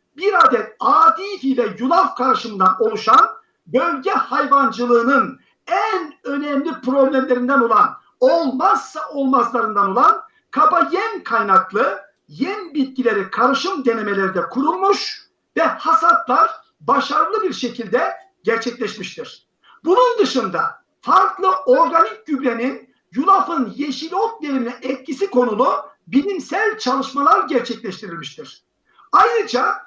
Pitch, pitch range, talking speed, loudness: 285 Hz, 245-390 Hz, 90 wpm, -17 LUFS